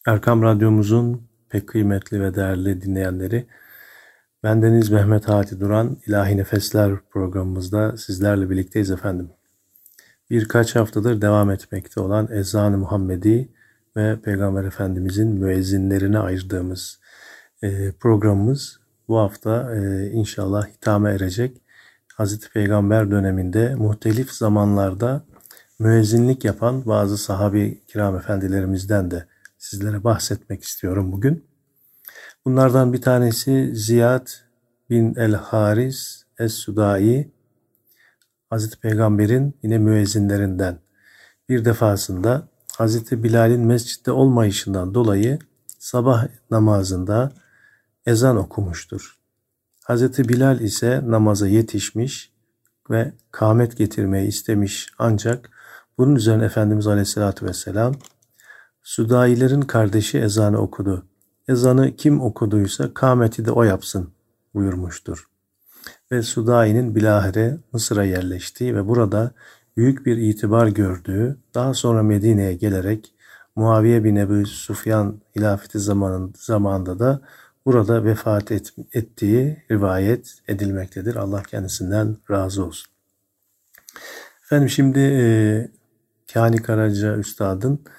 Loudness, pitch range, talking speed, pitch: -20 LUFS, 100-120 Hz, 95 wpm, 110 Hz